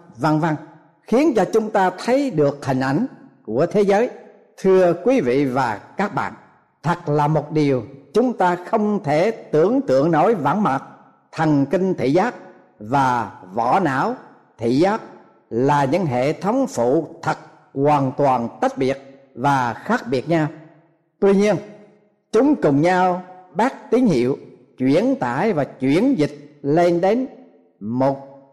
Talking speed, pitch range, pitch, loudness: 150 wpm, 140-205 Hz, 165 Hz, -19 LUFS